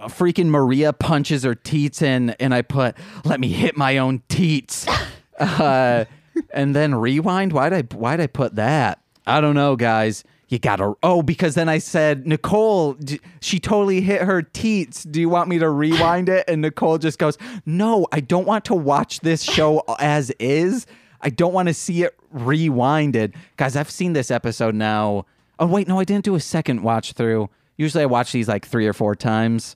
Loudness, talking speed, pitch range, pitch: -19 LUFS, 190 wpm, 125-175 Hz, 150 Hz